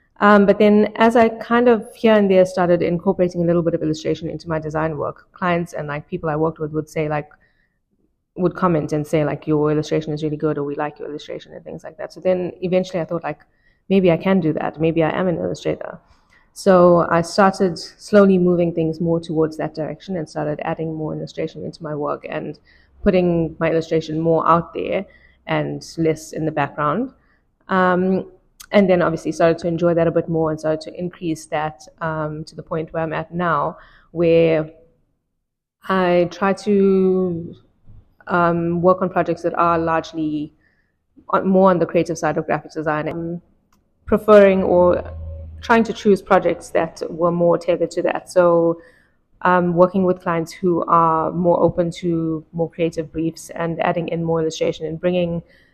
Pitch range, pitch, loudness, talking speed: 160-180 Hz, 170 Hz, -19 LUFS, 185 wpm